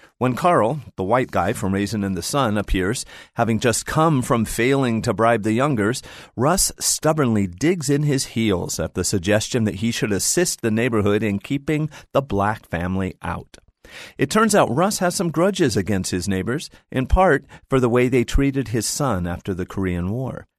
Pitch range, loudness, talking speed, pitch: 100-140 Hz, -21 LUFS, 185 wpm, 115 Hz